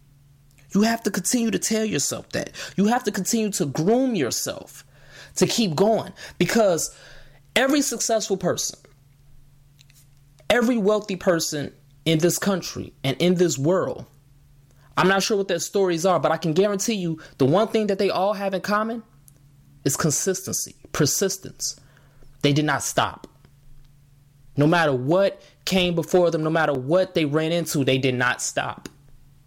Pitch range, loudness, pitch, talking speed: 140-195 Hz, -22 LUFS, 165 Hz, 155 wpm